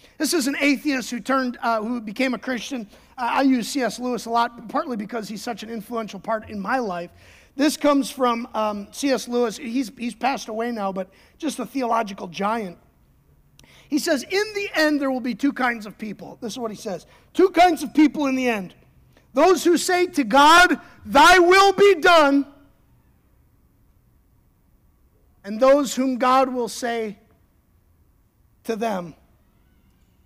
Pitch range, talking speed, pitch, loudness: 220-285 Hz, 170 wpm, 245 Hz, -20 LUFS